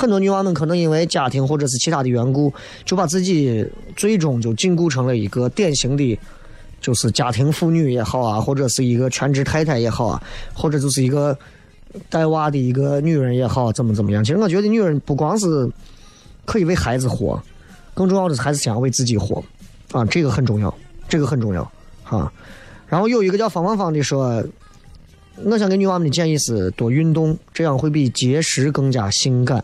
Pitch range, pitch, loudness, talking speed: 120-165 Hz, 140 Hz, -19 LUFS, 310 characters per minute